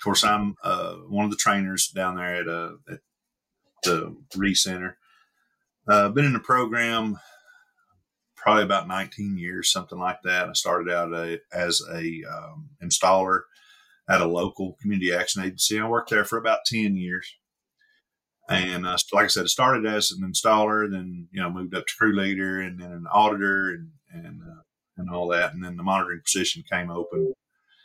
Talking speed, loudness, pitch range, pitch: 180 wpm, -24 LUFS, 90-115 Hz, 95 Hz